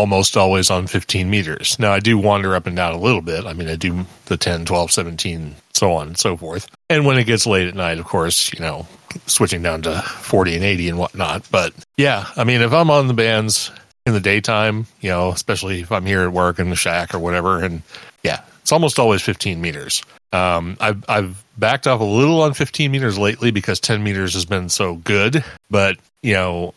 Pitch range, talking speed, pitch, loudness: 90-110 Hz, 225 wpm, 100 Hz, -17 LUFS